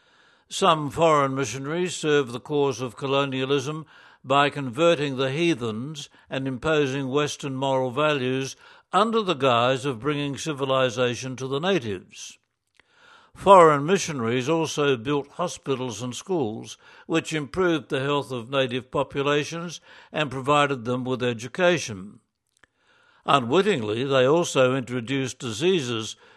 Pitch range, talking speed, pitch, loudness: 130-160 Hz, 115 wpm, 140 Hz, -24 LUFS